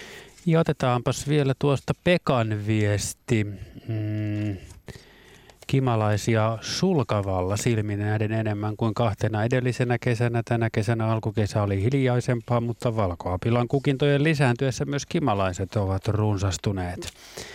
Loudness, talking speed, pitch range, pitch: -25 LUFS, 100 wpm, 105-130 Hz, 115 Hz